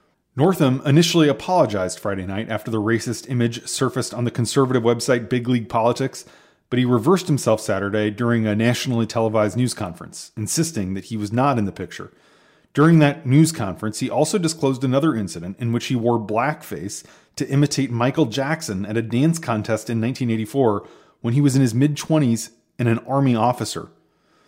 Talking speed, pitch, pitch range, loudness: 175 wpm, 120 Hz, 110-140 Hz, -20 LUFS